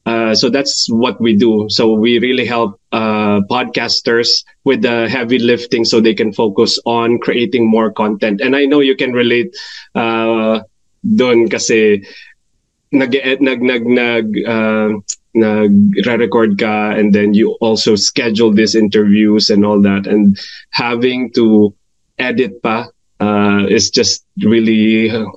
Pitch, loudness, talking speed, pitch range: 115 Hz, -12 LUFS, 140 wpm, 105-120 Hz